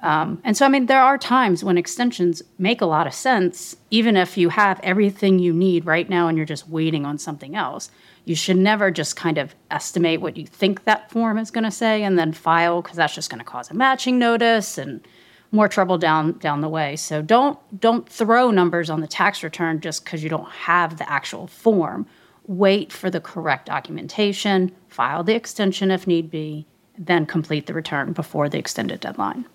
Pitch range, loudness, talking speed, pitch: 160-210 Hz, -20 LUFS, 205 wpm, 180 Hz